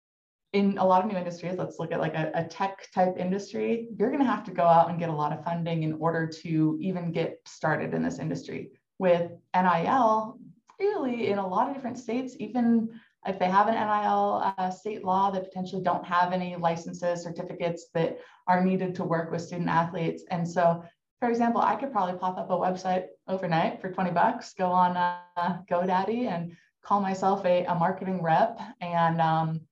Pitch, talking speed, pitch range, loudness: 185 Hz, 200 wpm, 170-200 Hz, -27 LUFS